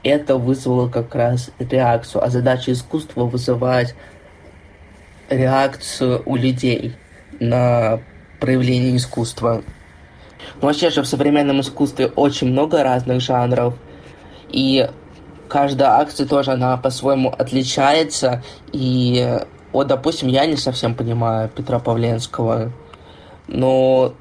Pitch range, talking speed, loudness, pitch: 115-135 Hz, 105 wpm, -18 LUFS, 125 Hz